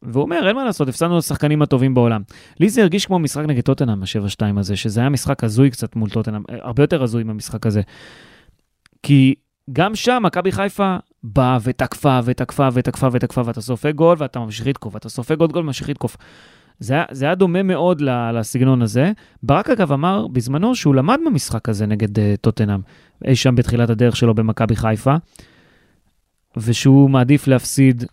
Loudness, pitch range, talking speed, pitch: -17 LUFS, 115-150 Hz, 170 wpm, 130 Hz